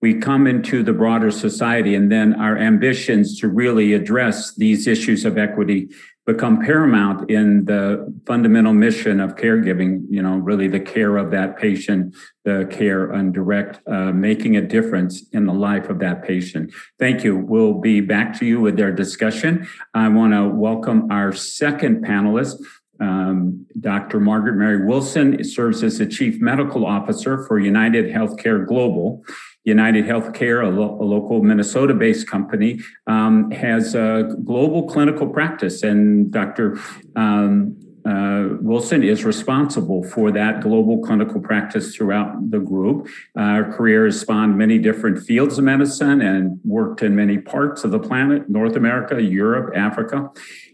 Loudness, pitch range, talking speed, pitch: -18 LUFS, 100-140 Hz, 155 wpm, 110 Hz